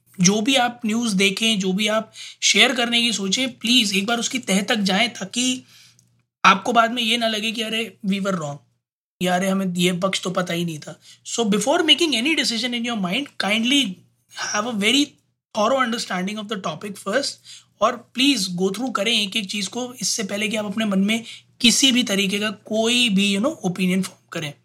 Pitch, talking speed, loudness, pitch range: 215 Hz, 205 wpm, -20 LUFS, 190-235 Hz